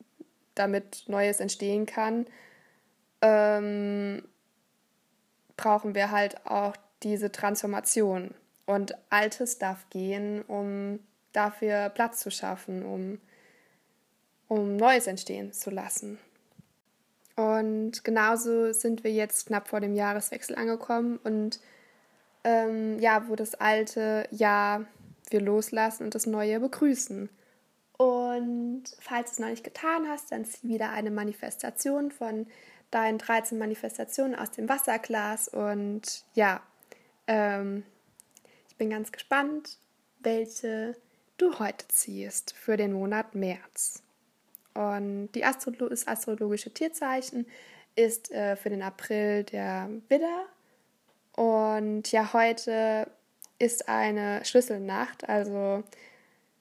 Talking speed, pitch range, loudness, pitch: 110 wpm, 205-235 Hz, -29 LUFS, 220 Hz